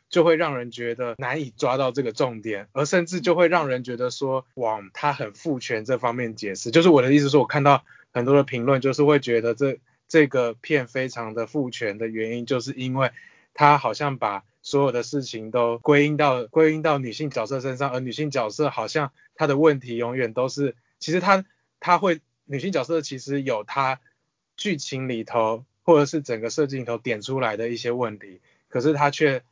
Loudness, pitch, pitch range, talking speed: -23 LUFS, 135 Hz, 120-150 Hz, 295 characters per minute